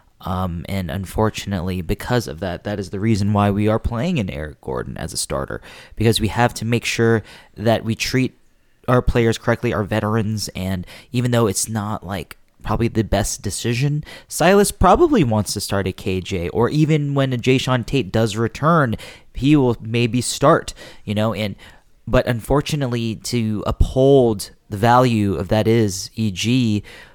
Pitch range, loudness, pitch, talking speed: 100-120 Hz, -19 LUFS, 110 Hz, 170 wpm